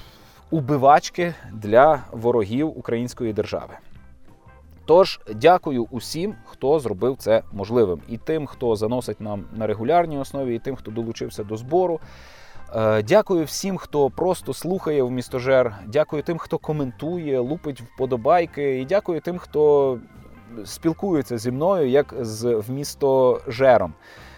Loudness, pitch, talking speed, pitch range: -22 LUFS, 130 Hz, 120 wpm, 115-155 Hz